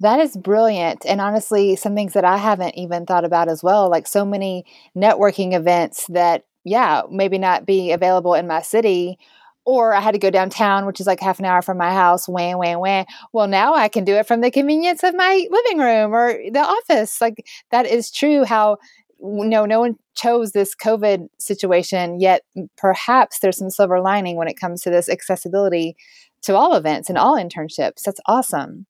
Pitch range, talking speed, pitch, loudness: 180-220 Hz, 200 wpm, 195 Hz, -17 LUFS